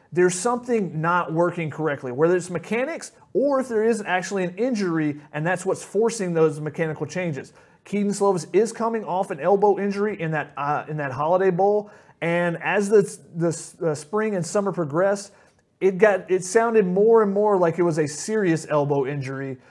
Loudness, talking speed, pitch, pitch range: -23 LUFS, 185 wpm, 180 Hz, 160-205 Hz